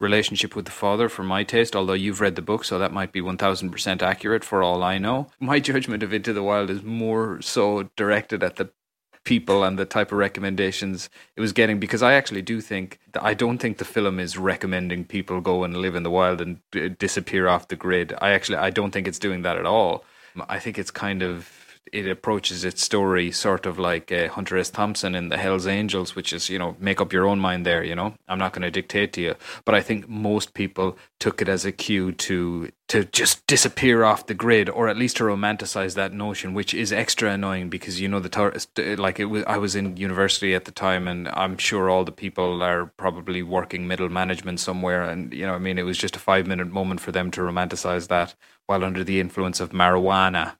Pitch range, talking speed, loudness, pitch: 90-100 Hz, 230 wpm, -23 LUFS, 95 Hz